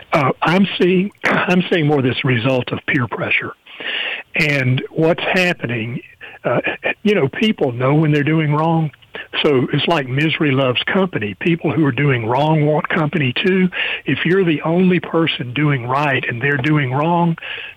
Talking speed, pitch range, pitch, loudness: 190 wpm, 140-180 Hz, 155 Hz, -17 LUFS